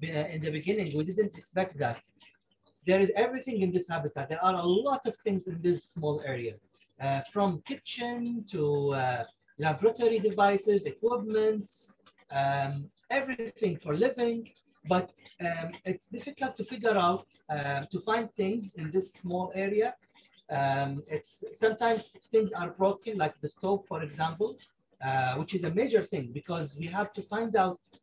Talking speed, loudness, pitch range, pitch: 155 wpm, -31 LUFS, 155-220 Hz, 185 Hz